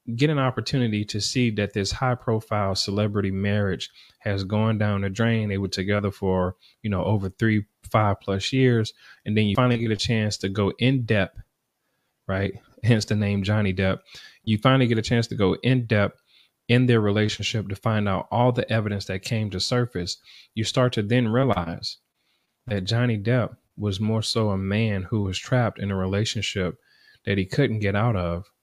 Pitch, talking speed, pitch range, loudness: 105 Hz, 190 wpm, 100-115 Hz, -24 LUFS